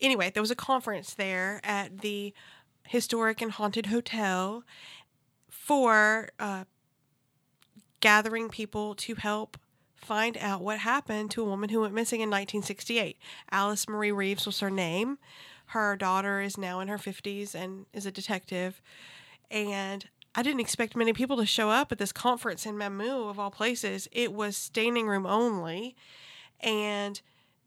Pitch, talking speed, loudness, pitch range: 210 Hz, 150 wpm, -30 LUFS, 195-225 Hz